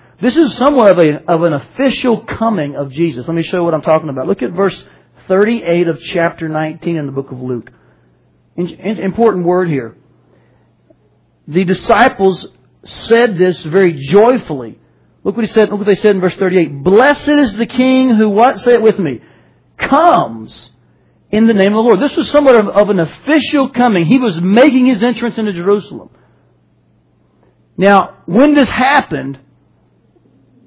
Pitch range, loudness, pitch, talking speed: 160-235 Hz, -12 LUFS, 190 Hz, 170 wpm